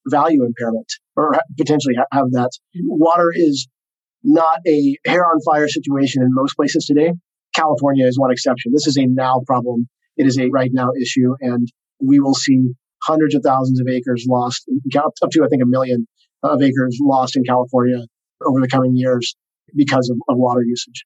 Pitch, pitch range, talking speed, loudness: 130 Hz, 125-155 Hz, 180 wpm, -16 LUFS